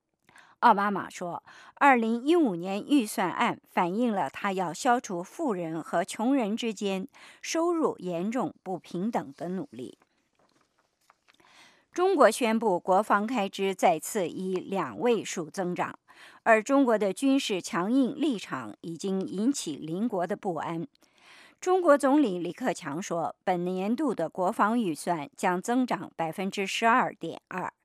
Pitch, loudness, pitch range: 205 Hz, -28 LUFS, 180-255 Hz